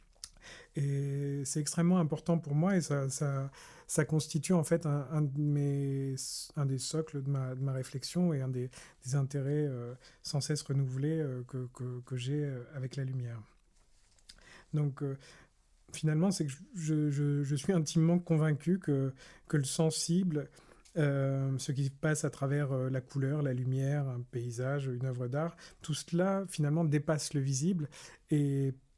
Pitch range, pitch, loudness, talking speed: 135-155 Hz, 145 Hz, -33 LUFS, 170 wpm